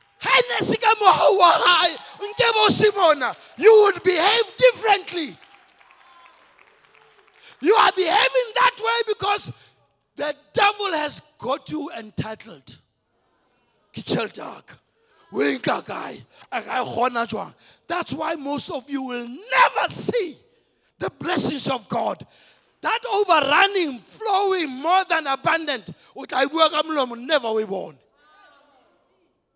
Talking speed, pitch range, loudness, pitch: 75 wpm, 275-415 Hz, -20 LUFS, 340 Hz